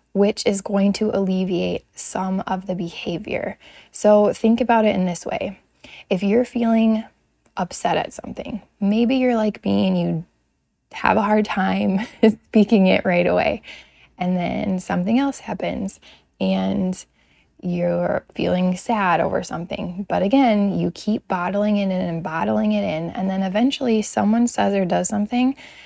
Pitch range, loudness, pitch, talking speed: 180-220 Hz, -20 LUFS, 200 Hz, 155 wpm